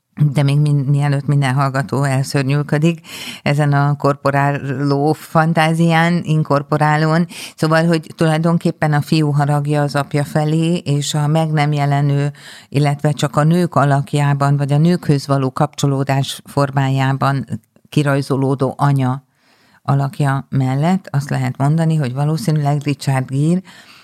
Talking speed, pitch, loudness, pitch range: 120 wpm, 145 Hz, -16 LUFS, 140-155 Hz